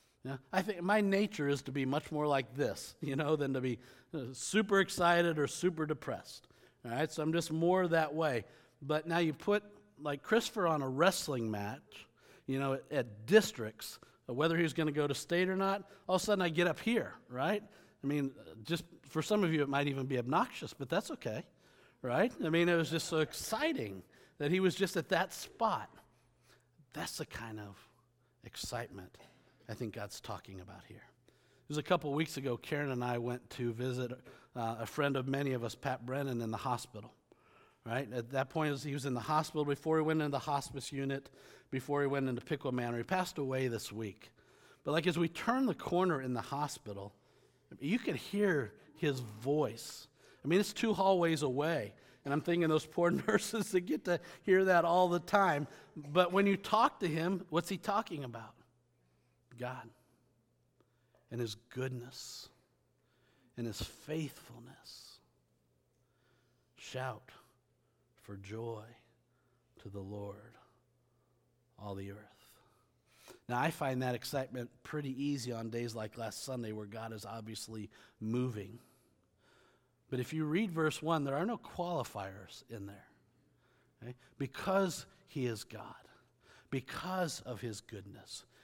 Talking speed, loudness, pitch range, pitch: 170 wpm, -36 LUFS, 120-165 Hz, 140 Hz